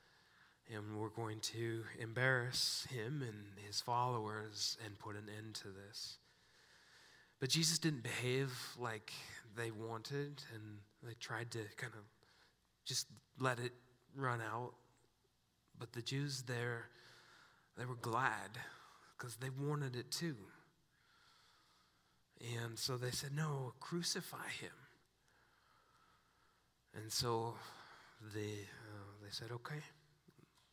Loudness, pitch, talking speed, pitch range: -43 LUFS, 120 Hz, 115 wpm, 110-130 Hz